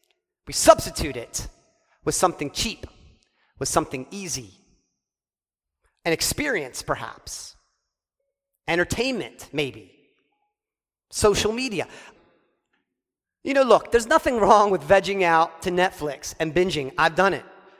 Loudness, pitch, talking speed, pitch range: -22 LUFS, 195 Hz, 110 wpm, 165-265 Hz